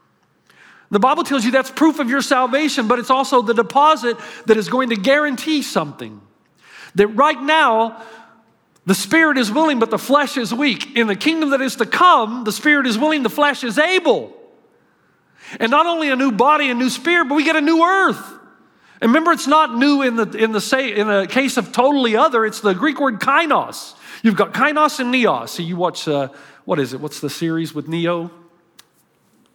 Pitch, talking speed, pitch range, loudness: 255 Hz, 205 wpm, 215-295 Hz, -16 LUFS